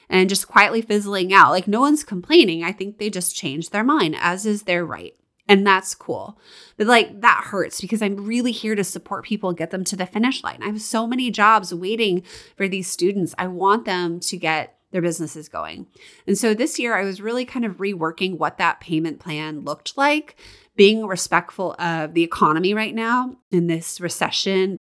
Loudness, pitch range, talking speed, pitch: -20 LUFS, 175-220 Hz, 200 wpm, 195 Hz